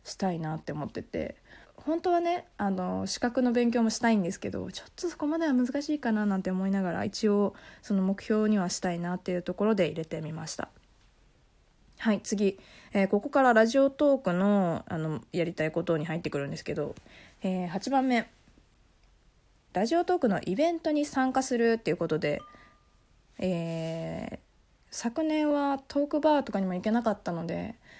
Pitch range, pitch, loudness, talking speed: 175-265 Hz, 205 Hz, -29 LUFS, 355 characters per minute